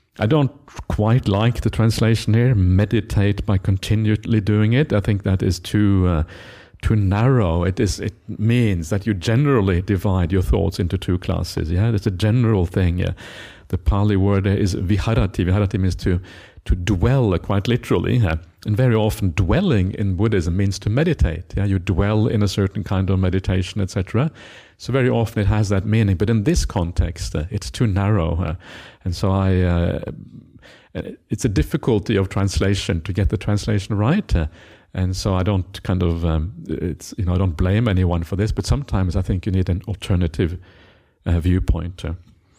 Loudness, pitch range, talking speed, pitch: -20 LUFS, 90-110 Hz, 185 wpm, 100 Hz